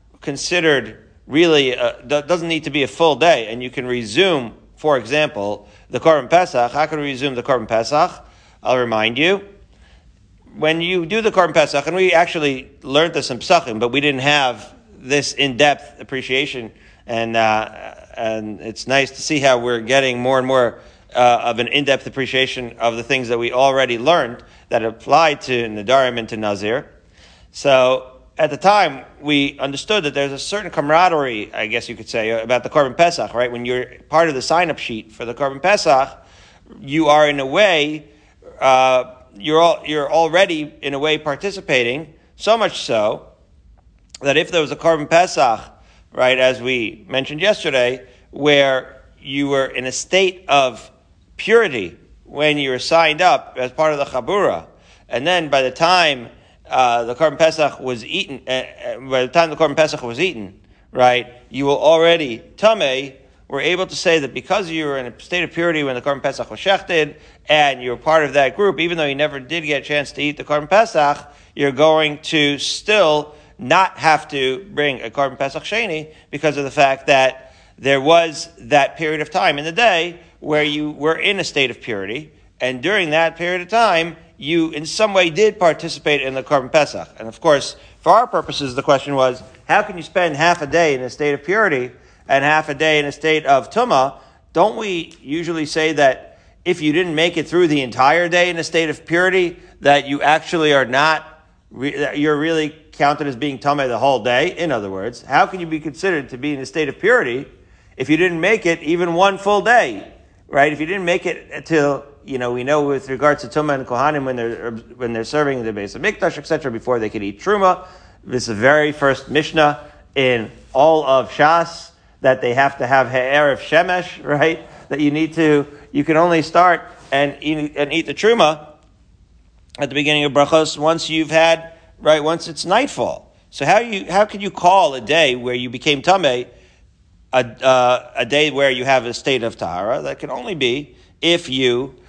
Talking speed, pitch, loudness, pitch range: 200 wpm, 145 Hz, -17 LUFS, 130-160 Hz